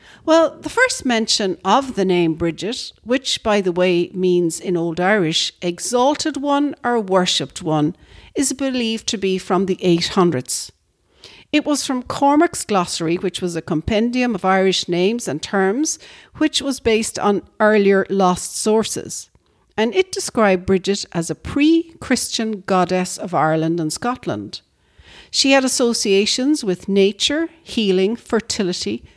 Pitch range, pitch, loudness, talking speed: 180-255 Hz, 200 Hz, -18 LUFS, 140 wpm